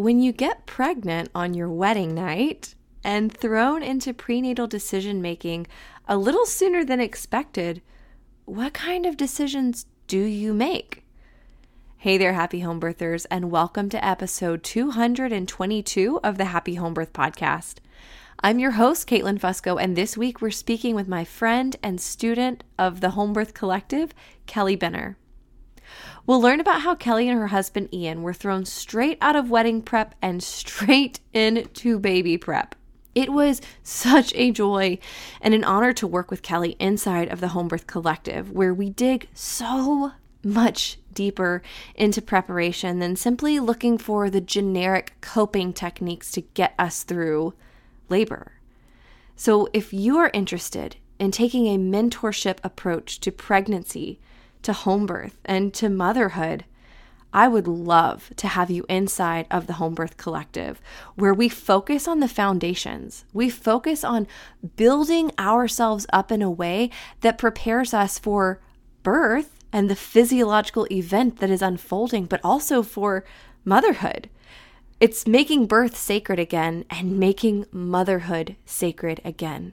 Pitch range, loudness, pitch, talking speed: 180-235 Hz, -23 LUFS, 205 Hz, 150 wpm